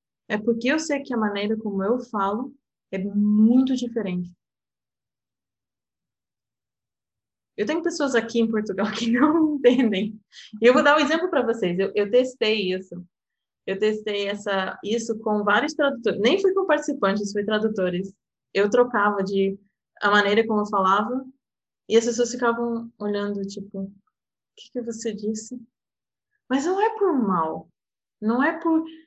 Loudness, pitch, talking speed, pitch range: -23 LUFS, 220 Hz, 155 wpm, 205-255 Hz